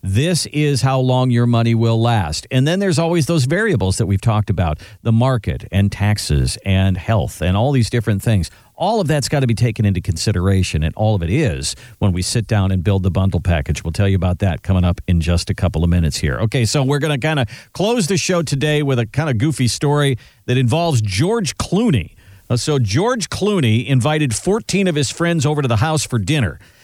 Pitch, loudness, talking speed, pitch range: 115 Hz, -17 LUFS, 230 wpm, 95-145 Hz